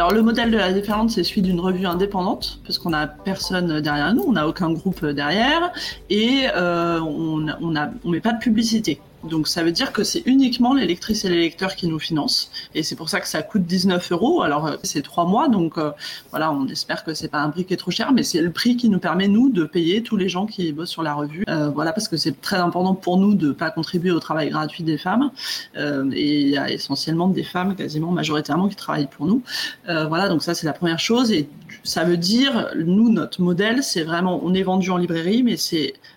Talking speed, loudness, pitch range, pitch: 240 wpm, -21 LUFS, 160-215 Hz, 180 Hz